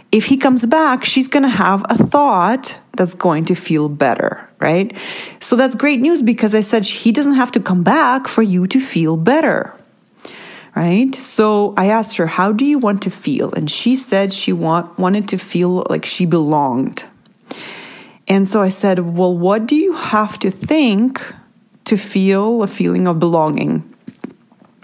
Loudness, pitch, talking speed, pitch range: -15 LUFS, 210 Hz, 175 wpm, 180-250 Hz